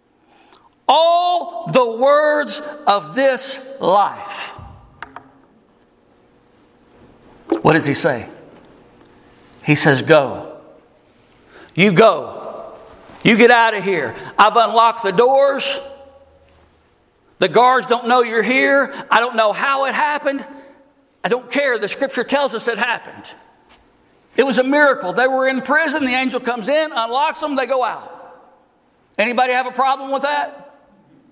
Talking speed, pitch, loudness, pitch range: 130 wpm, 255 Hz, -16 LUFS, 205-275 Hz